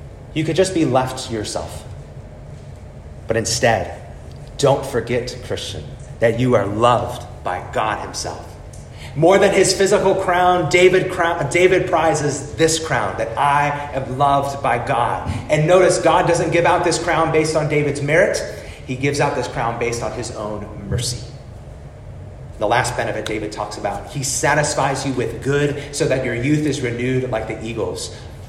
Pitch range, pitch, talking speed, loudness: 115-160 Hz, 135 Hz, 165 wpm, -18 LUFS